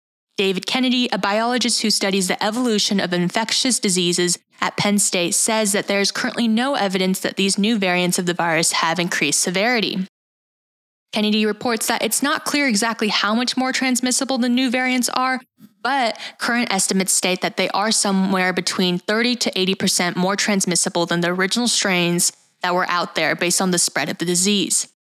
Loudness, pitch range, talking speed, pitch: -18 LUFS, 180-230 Hz, 180 wpm, 200 Hz